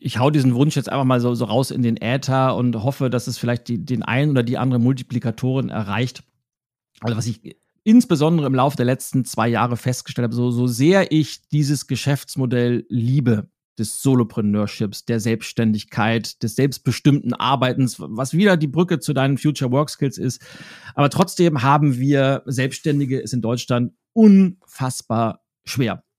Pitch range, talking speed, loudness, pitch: 120-145 Hz, 165 wpm, -19 LUFS, 130 Hz